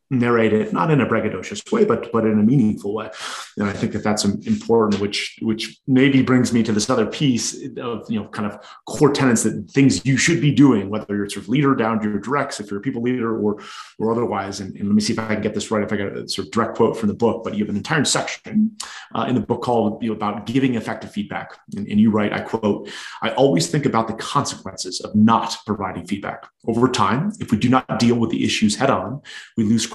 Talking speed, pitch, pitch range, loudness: 255 wpm, 115 Hz, 105-130 Hz, -20 LUFS